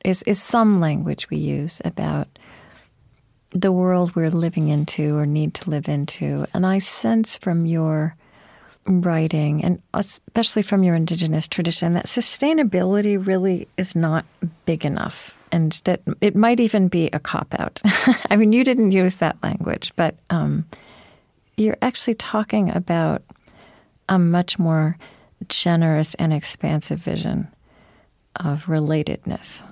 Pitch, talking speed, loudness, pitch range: 175 Hz, 135 wpm, -20 LUFS, 155-200 Hz